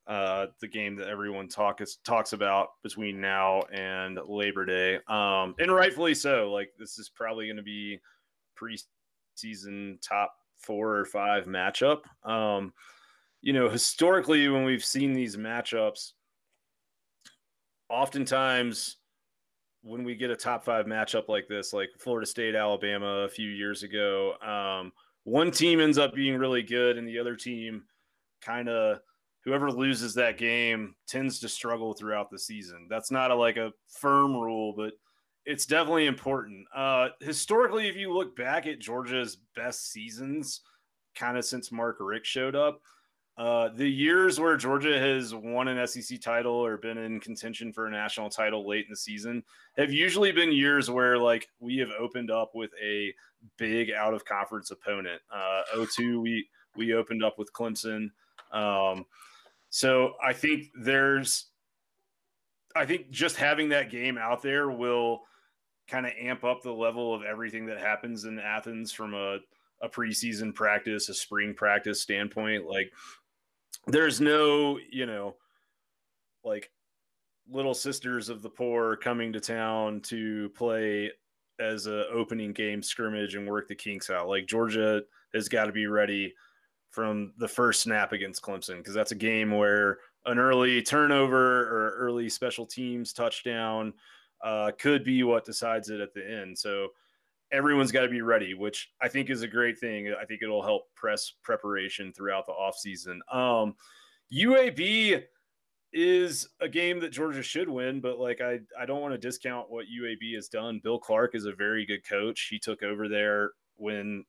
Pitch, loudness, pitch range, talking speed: 115 Hz, -29 LUFS, 105-130 Hz, 160 wpm